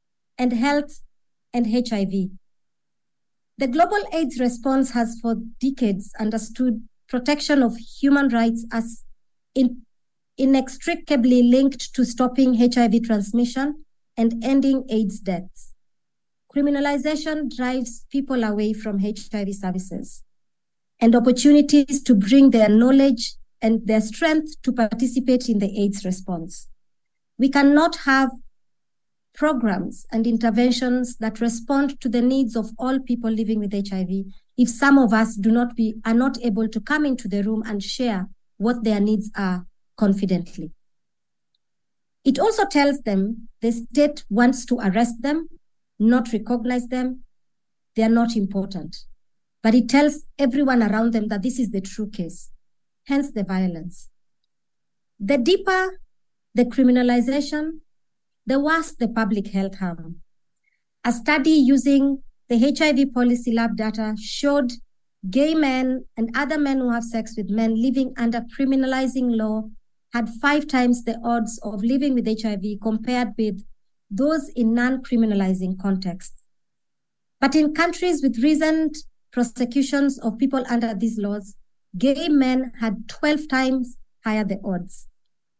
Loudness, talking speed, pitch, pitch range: -21 LUFS, 130 wpm, 240 Hz, 220-270 Hz